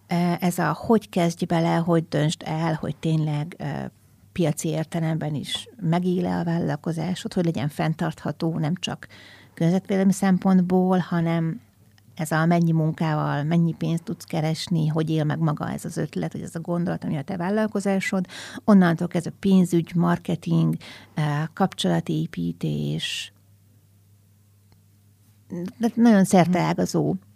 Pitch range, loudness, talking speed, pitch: 150-180 Hz, -24 LUFS, 130 wpm, 165 Hz